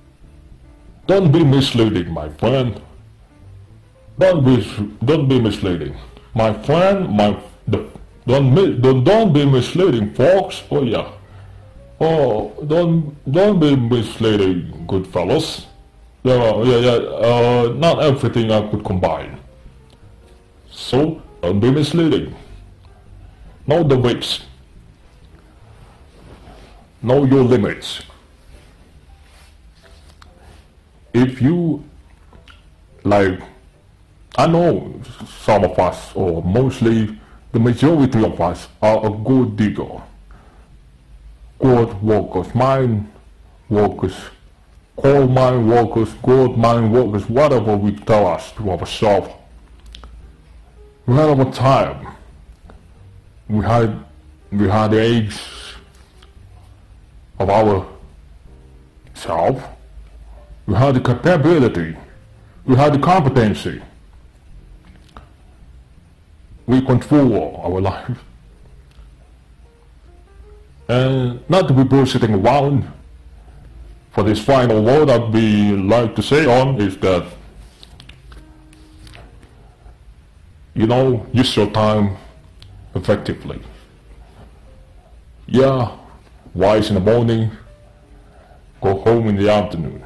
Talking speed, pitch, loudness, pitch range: 95 wpm, 100 Hz, -16 LUFS, 75-120 Hz